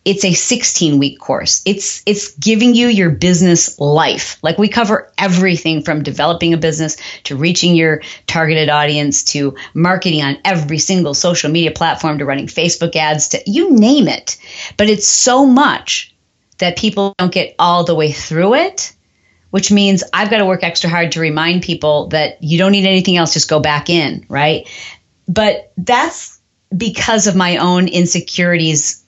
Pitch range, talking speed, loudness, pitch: 155-195 Hz, 170 wpm, -13 LUFS, 175 Hz